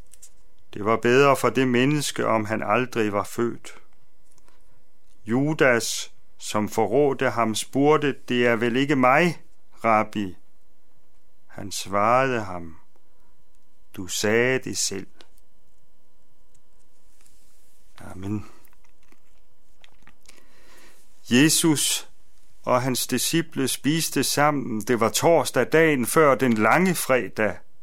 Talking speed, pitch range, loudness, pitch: 95 wpm, 105-140 Hz, -22 LUFS, 120 Hz